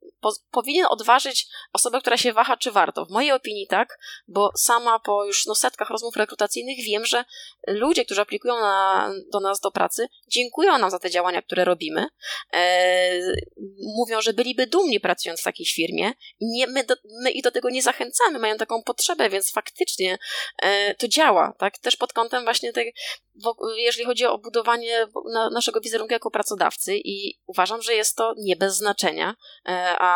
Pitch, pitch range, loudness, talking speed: 230 Hz, 200-255 Hz, -22 LUFS, 175 wpm